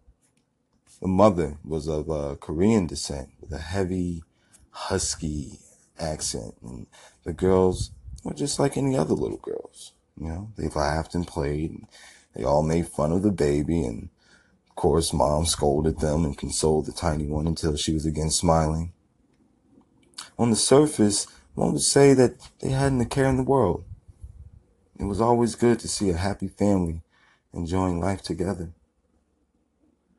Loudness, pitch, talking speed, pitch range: -24 LUFS, 85 Hz, 155 wpm, 80-100 Hz